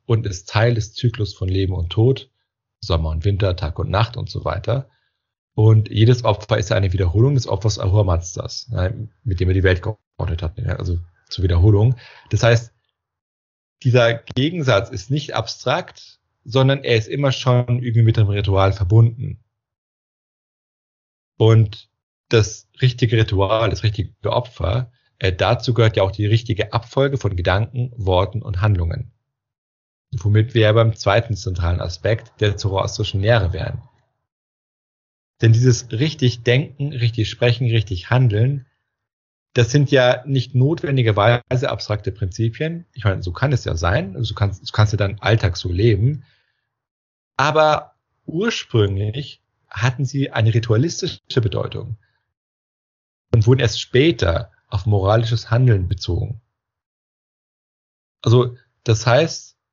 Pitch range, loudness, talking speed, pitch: 100-125 Hz, -19 LUFS, 135 wpm, 115 Hz